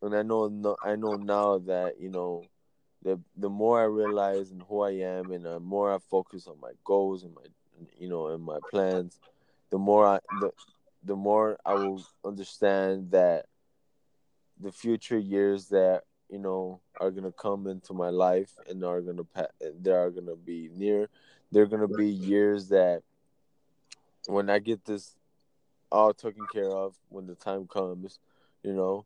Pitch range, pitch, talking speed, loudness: 95-105 Hz, 100 Hz, 180 wpm, -29 LUFS